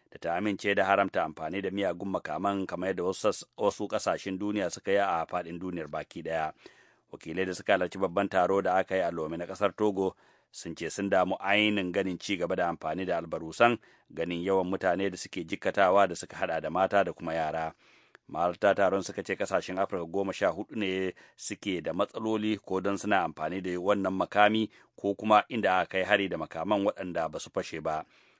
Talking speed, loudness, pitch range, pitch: 195 wpm, -30 LUFS, 90-100 Hz, 95 Hz